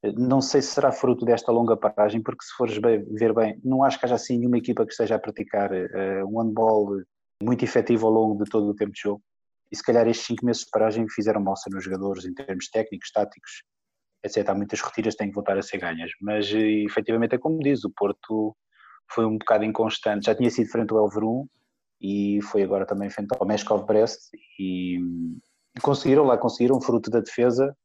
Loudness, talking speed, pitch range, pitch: -24 LUFS, 210 wpm, 100-120 Hz, 110 Hz